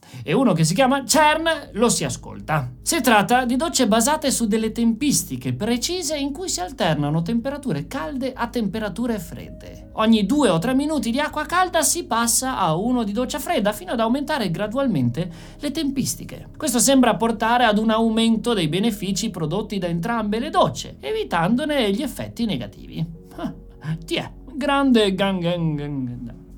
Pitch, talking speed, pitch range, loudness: 230 Hz, 160 wpm, 175-270 Hz, -21 LUFS